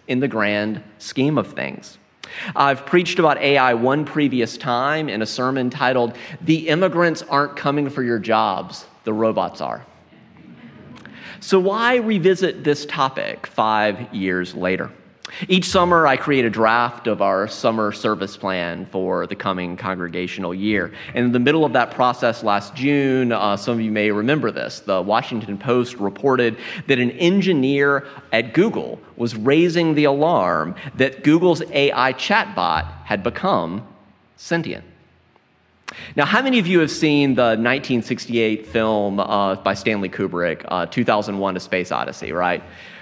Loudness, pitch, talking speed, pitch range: -19 LUFS, 125 Hz, 150 wpm, 105-150 Hz